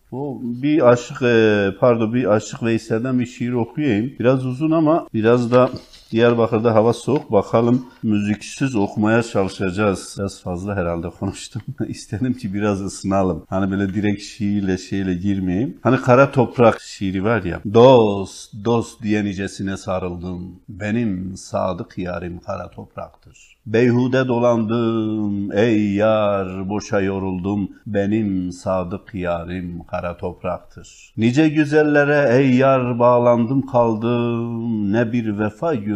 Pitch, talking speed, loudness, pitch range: 110 Hz, 125 wpm, -19 LUFS, 95-120 Hz